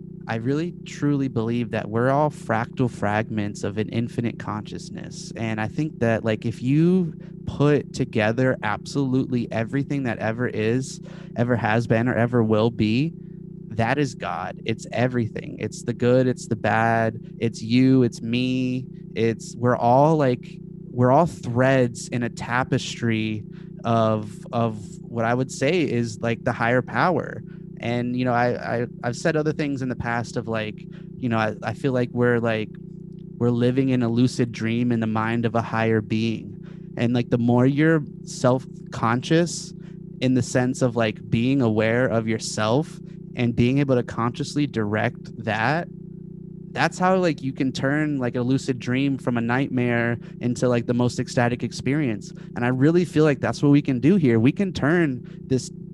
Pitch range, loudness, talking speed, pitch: 115-160 Hz, -23 LUFS, 175 wpm, 125 Hz